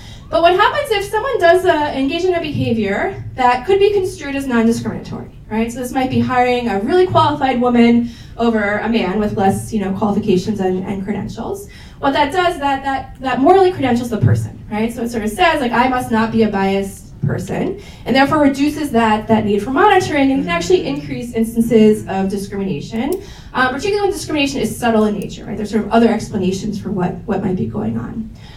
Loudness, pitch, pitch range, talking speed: -16 LUFS, 235 Hz, 210-290 Hz, 205 wpm